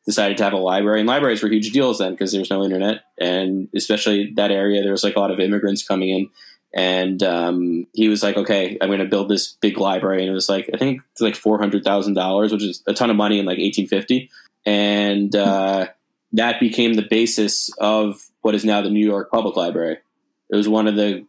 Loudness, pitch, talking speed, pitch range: -19 LUFS, 100 Hz, 230 wpm, 95-105 Hz